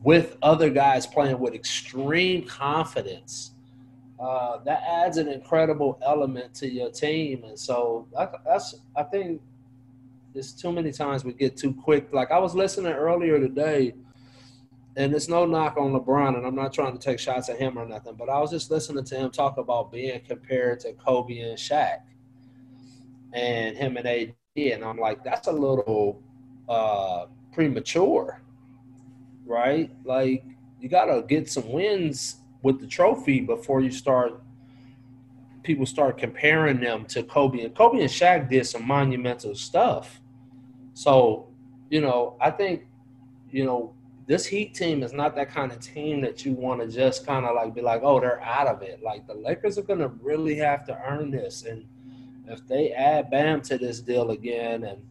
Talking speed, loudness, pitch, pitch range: 175 wpm, -25 LUFS, 130 Hz, 125-145 Hz